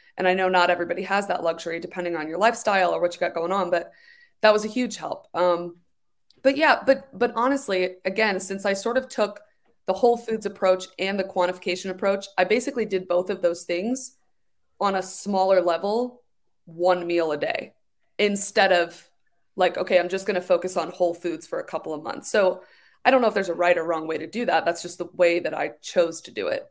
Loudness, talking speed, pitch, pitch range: -23 LUFS, 225 wpm, 190 Hz, 175-220 Hz